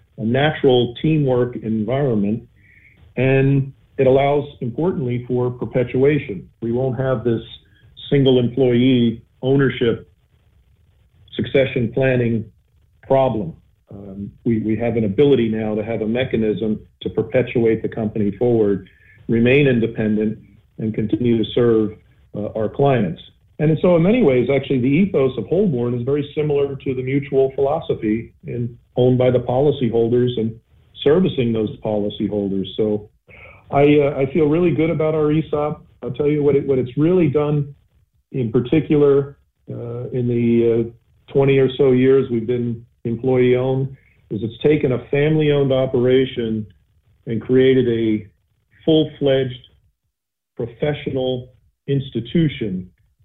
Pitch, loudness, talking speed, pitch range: 125 Hz, -18 LUFS, 130 wpm, 110-135 Hz